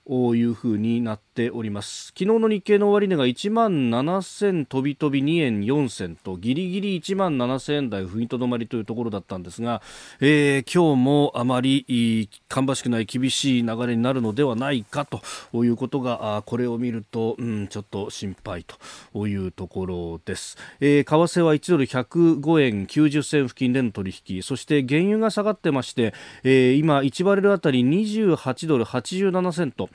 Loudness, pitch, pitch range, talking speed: -22 LUFS, 130 Hz, 115-155 Hz, 345 characters per minute